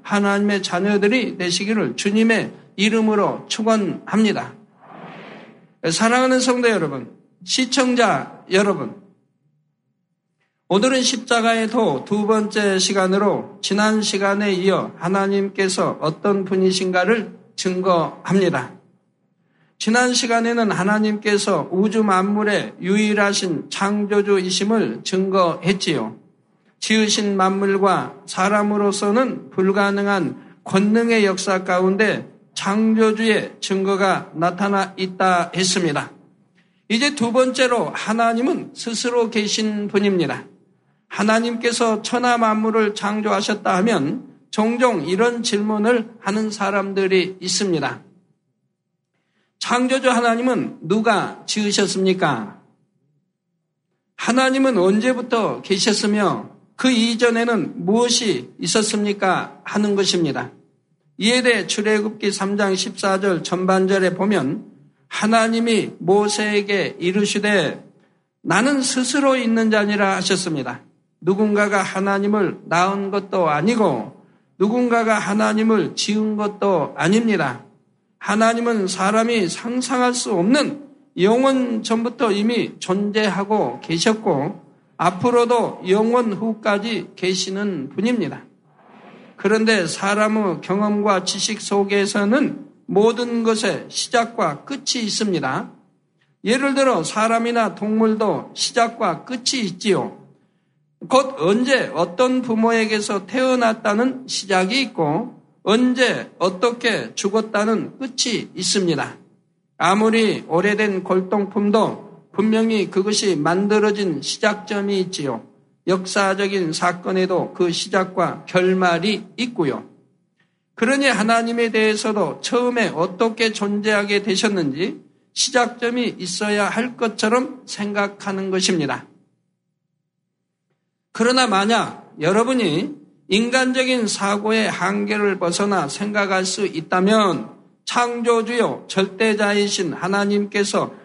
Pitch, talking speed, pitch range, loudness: 205 Hz, 245 characters per minute, 185-225 Hz, -19 LUFS